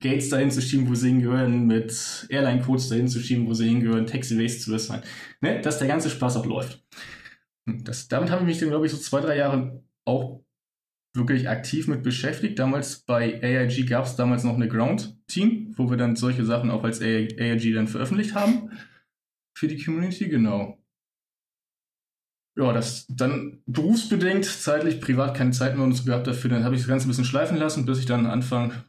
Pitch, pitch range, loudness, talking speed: 130 Hz, 120-145 Hz, -24 LUFS, 185 wpm